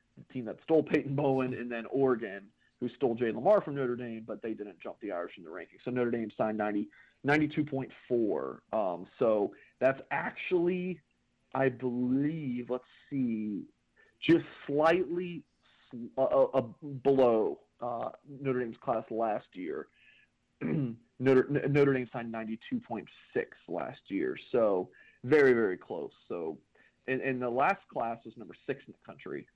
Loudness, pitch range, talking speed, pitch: -32 LUFS, 120-150 Hz, 150 wpm, 130 Hz